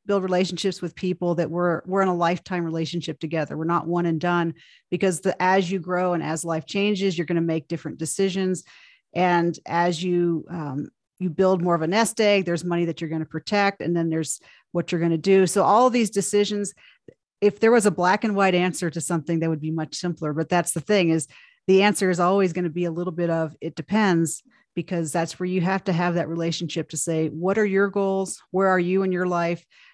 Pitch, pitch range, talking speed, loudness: 175 Hz, 165-190 Hz, 235 wpm, -23 LUFS